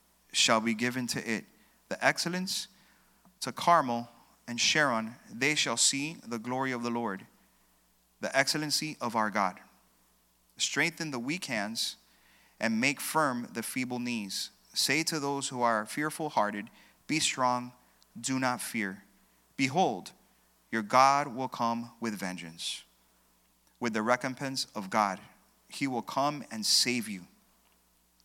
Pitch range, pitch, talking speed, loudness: 95-135 Hz, 120 Hz, 135 wpm, -30 LUFS